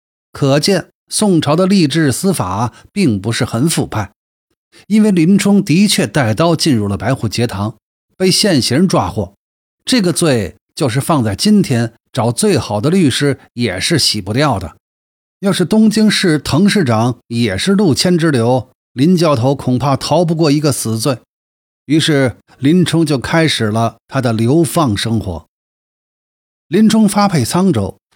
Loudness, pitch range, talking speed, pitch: -13 LUFS, 115-175 Hz, 215 characters per minute, 145 Hz